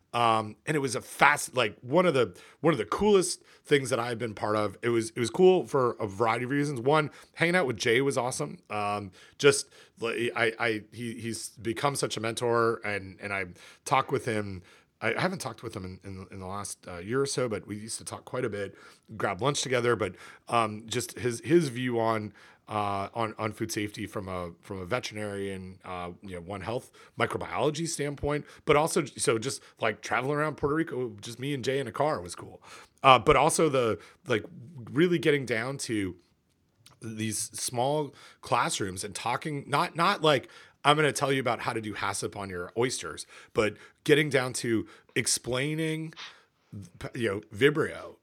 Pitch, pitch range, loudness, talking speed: 115 Hz, 105-145 Hz, -28 LUFS, 200 wpm